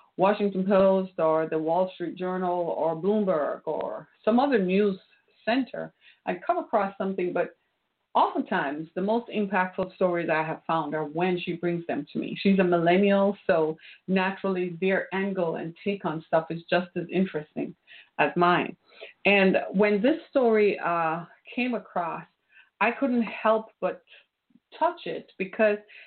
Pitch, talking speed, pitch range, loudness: 190 Hz, 150 wpm, 170-210 Hz, -26 LUFS